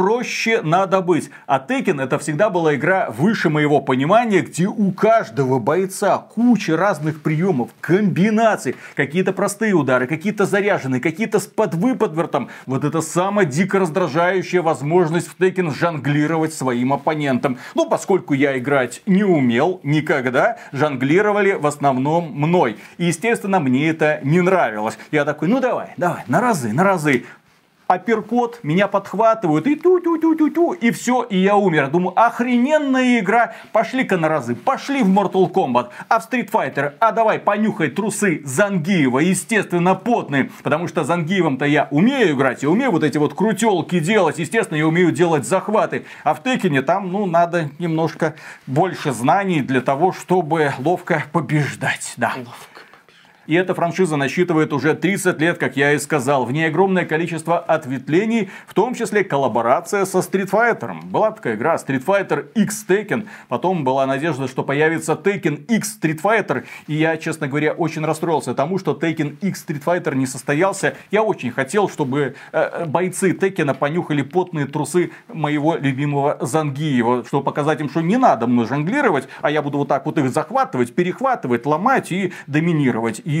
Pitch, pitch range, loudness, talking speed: 170 Hz, 150-200 Hz, -18 LUFS, 155 wpm